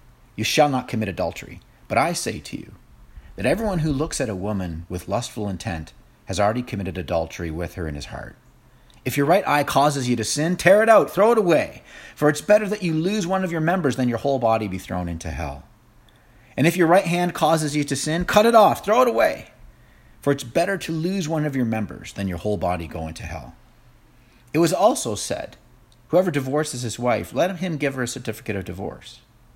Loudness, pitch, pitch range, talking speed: -22 LUFS, 125 Hz, 105-160 Hz, 220 wpm